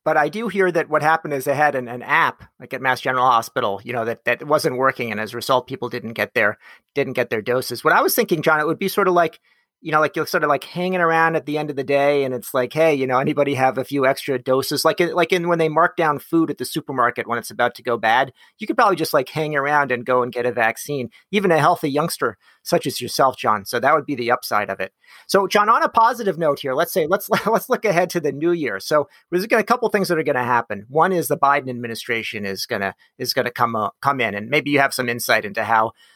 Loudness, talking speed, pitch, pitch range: -20 LUFS, 285 wpm, 145 Hz, 125-170 Hz